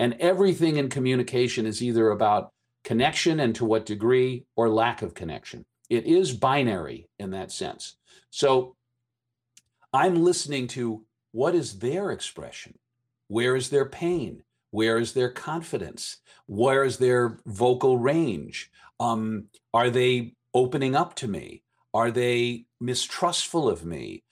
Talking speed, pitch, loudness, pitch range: 135 wpm, 120 Hz, -25 LUFS, 115-130 Hz